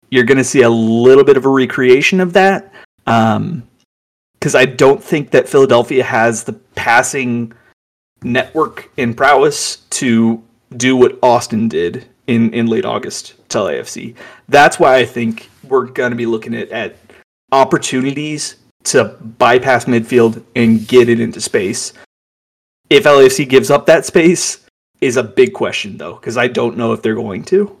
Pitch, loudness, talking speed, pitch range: 125 Hz, -12 LUFS, 160 wpm, 115-150 Hz